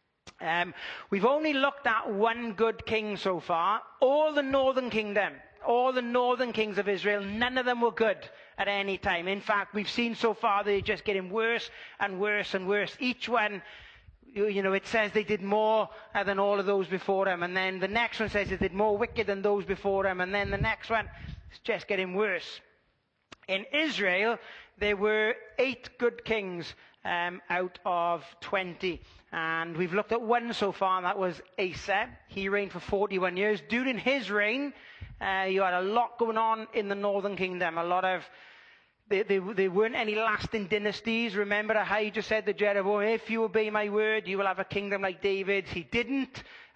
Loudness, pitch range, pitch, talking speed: -29 LUFS, 195-225 Hz, 205 Hz, 195 wpm